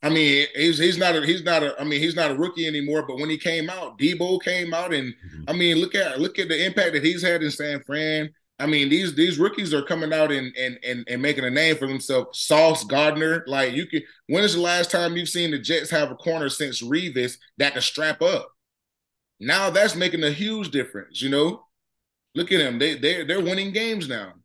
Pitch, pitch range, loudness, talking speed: 155 Hz, 145-175 Hz, -22 LUFS, 235 wpm